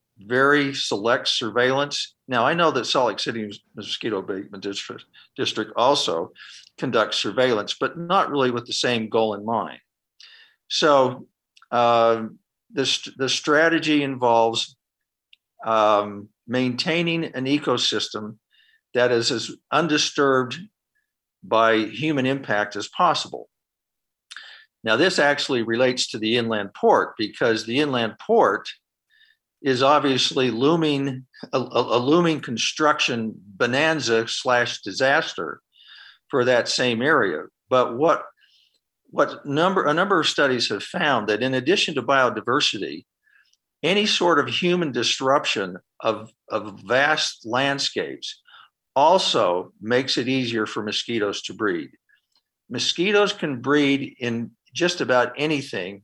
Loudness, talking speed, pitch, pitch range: -21 LUFS, 115 wpm, 130 Hz, 115-155 Hz